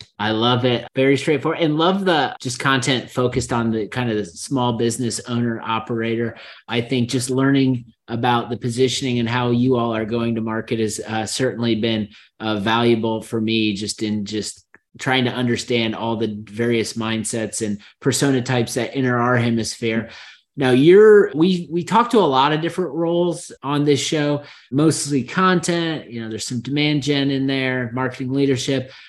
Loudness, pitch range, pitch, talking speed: -19 LUFS, 115-140 Hz, 125 Hz, 175 wpm